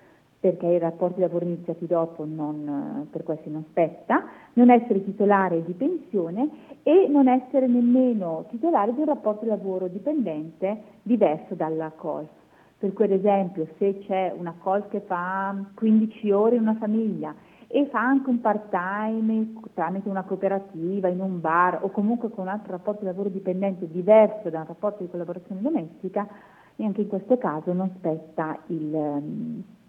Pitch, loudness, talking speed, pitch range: 195 Hz, -25 LUFS, 155 wpm, 175-220 Hz